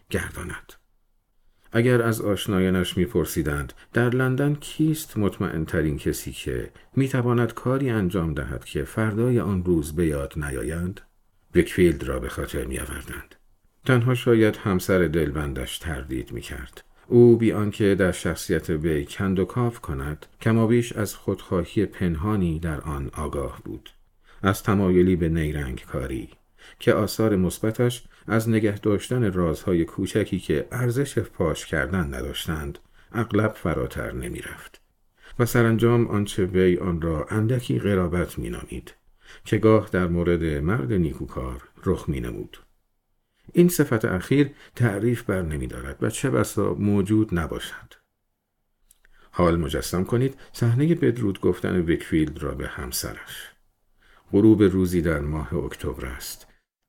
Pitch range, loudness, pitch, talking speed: 80-115 Hz, -24 LUFS, 95 Hz, 130 wpm